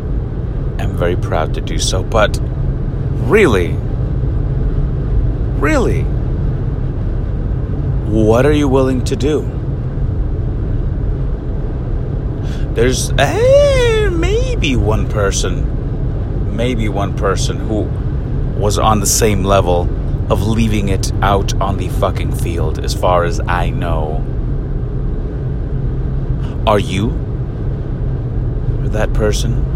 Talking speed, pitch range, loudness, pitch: 95 wpm, 105-130 Hz, -16 LUFS, 120 Hz